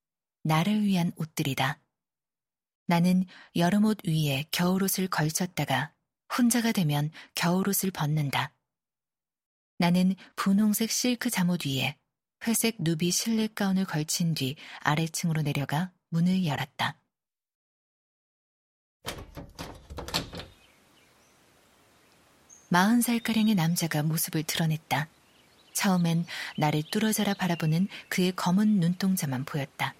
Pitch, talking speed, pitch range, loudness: 175 Hz, 220 characters per minute, 150-195 Hz, -27 LUFS